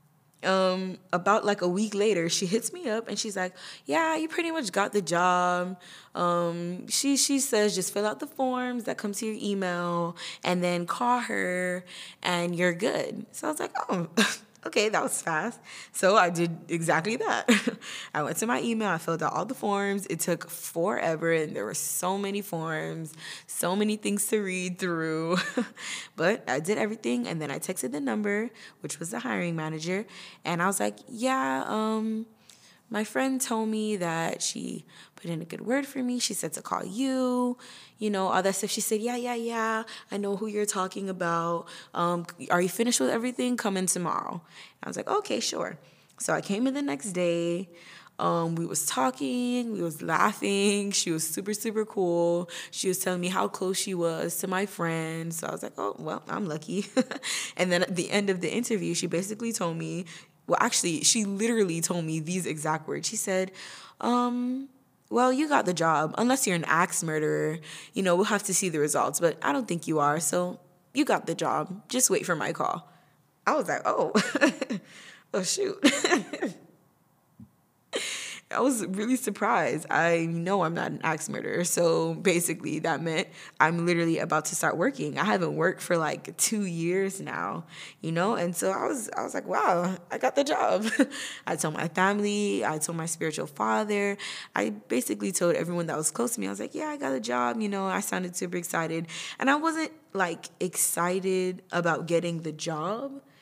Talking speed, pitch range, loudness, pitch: 195 wpm, 170-220 Hz, -28 LUFS, 185 Hz